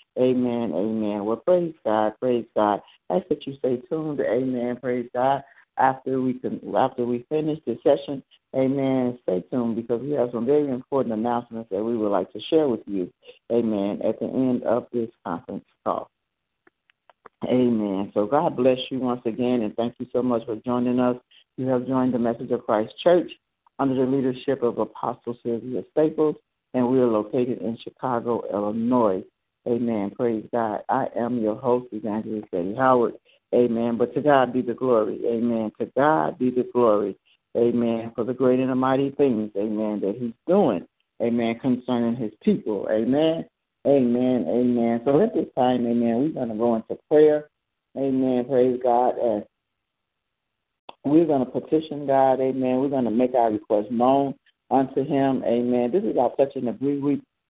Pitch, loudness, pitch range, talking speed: 125 Hz, -23 LUFS, 115-130 Hz, 175 wpm